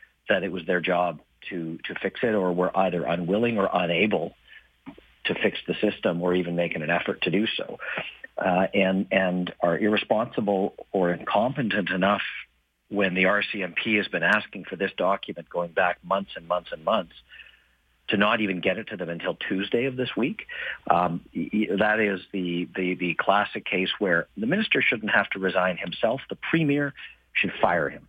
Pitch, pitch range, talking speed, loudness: 90 Hz, 85-100 Hz, 180 wpm, -25 LUFS